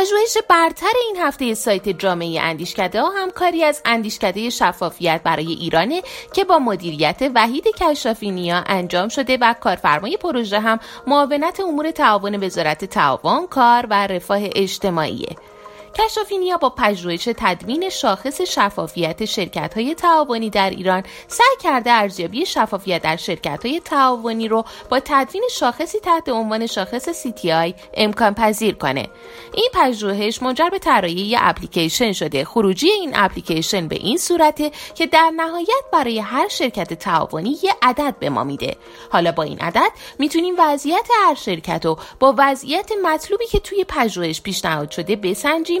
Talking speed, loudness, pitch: 140 wpm, -18 LUFS, 240 Hz